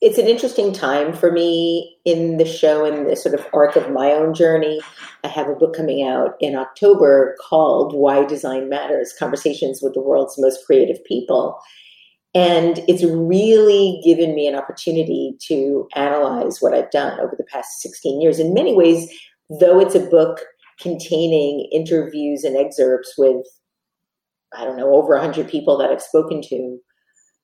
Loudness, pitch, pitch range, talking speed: -17 LUFS, 160 Hz, 145-170 Hz, 165 wpm